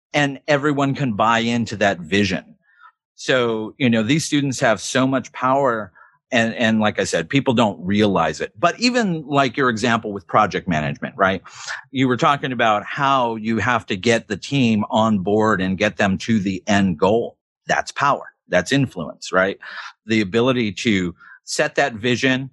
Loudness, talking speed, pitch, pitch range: -19 LUFS, 175 wpm, 115 Hz, 105-135 Hz